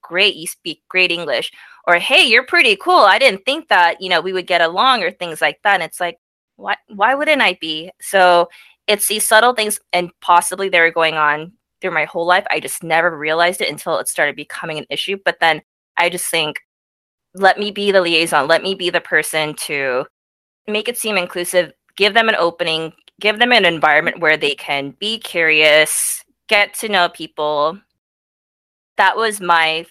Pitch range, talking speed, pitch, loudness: 160-205 Hz, 195 wpm, 175 Hz, -15 LUFS